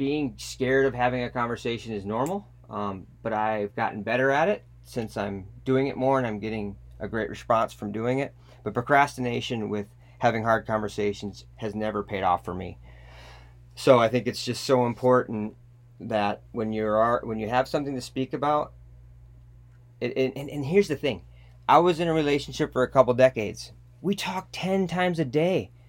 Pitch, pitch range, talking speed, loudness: 120 Hz, 105-130 Hz, 185 wpm, -26 LUFS